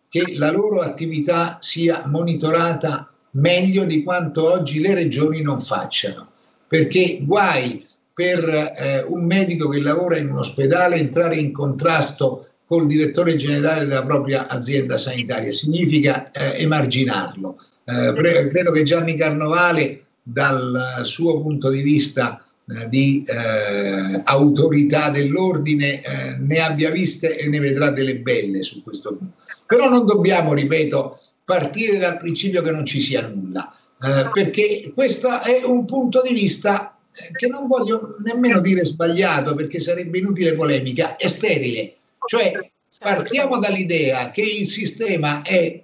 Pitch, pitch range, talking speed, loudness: 160 Hz, 140-180 Hz, 135 wpm, -19 LUFS